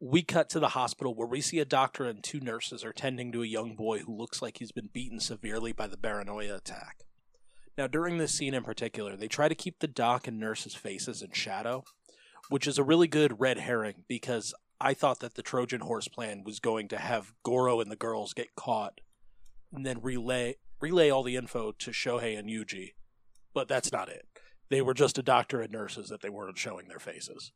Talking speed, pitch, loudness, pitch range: 220 wpm, 120 Hz, -32 LUFS, 110-135 Hz